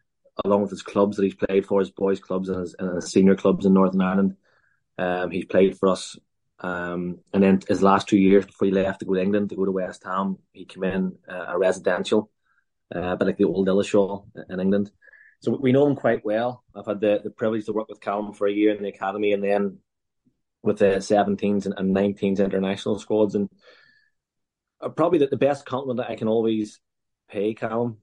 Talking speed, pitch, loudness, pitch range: 210 wpm, 100 Hz, -23 LUFS, 95-105 Hz